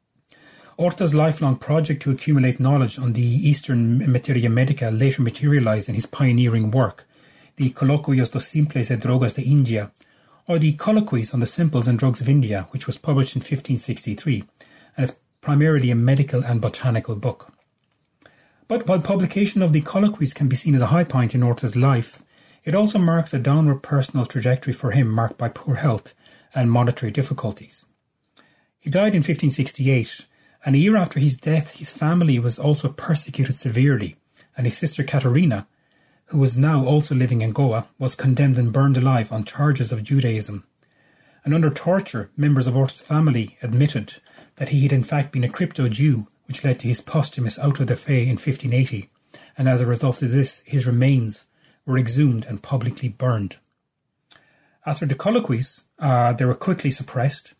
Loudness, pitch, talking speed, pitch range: -21 LUFS, 135 Hz, 170 wpm, 125-145 Hz